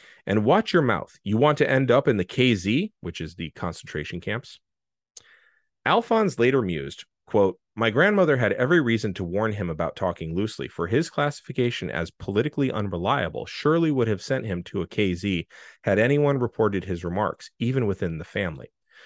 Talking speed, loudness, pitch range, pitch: 175 wpm, -24 LUFS, 90-145 Hz, 110 Hz